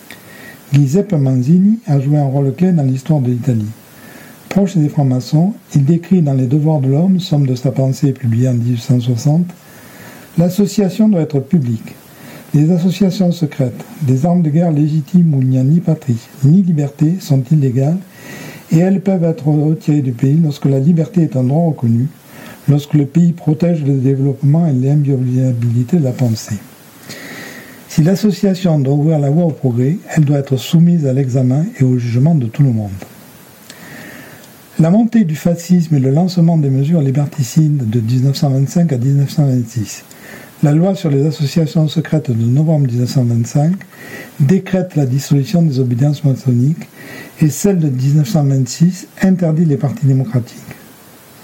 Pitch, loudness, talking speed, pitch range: 150 Hz, -14 LUFS, 155 wpm, 130-170 Hz